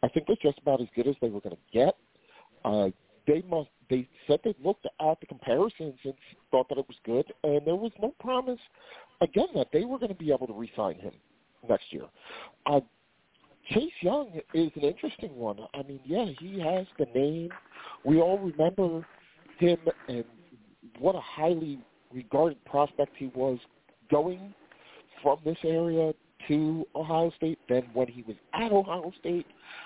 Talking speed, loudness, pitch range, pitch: 175 wpm, -29 LUFS, 135-175 Hz, 155 Hz